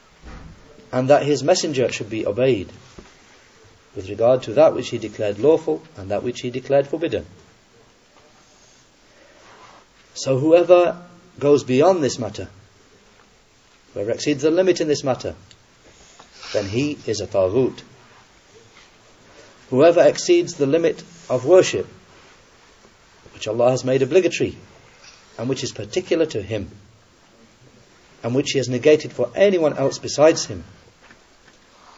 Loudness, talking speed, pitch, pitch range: -19 LUFS, 125 wpm, 135 Hz, 120-160 Hz